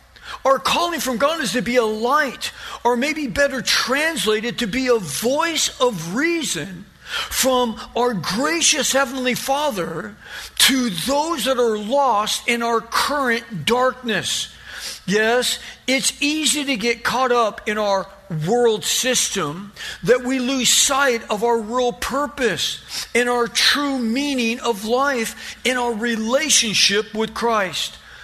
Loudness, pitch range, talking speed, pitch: -19 LUFS, 225-270 Hz, 135 wpm, 245 Hz